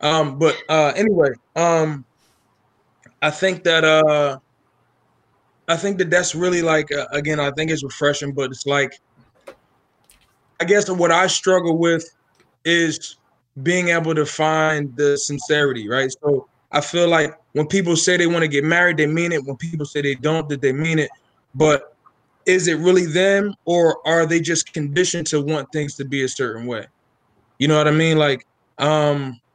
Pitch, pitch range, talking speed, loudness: 155 Hz, 140-170 Hz, 175 wpm, -19 LUFS